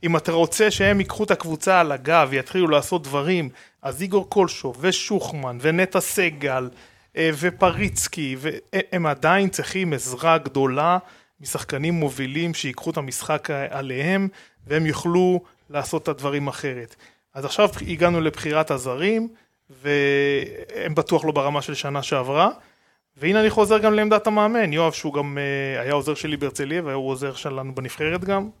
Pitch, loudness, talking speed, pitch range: 155 Hz, -22 LUFS, 140 wpm, 140-185 Hz